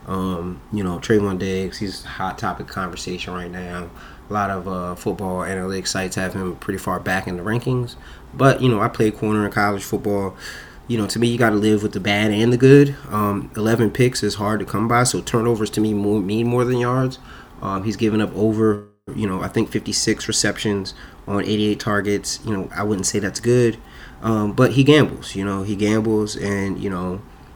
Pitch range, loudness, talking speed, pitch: 95-110 Hz, -20 LUFS, 215 wpm, 105 Hz